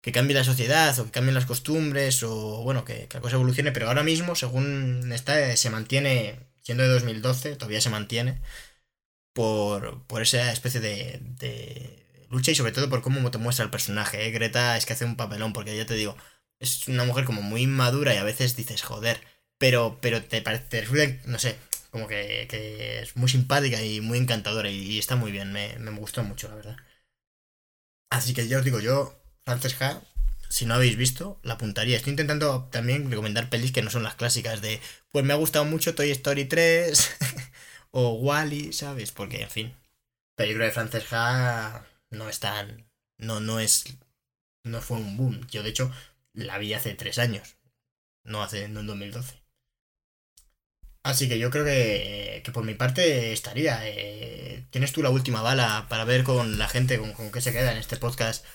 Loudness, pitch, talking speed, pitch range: -26 LUFS, 120 Hz, 195 wpm, 110-130 Hz